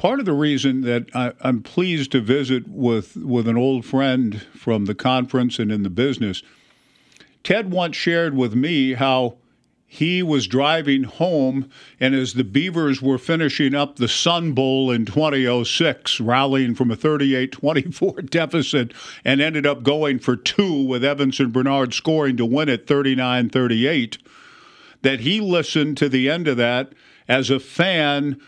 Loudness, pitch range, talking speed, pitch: -20 LUFS, 125-150 Hz, 160 wpm, 135 Hz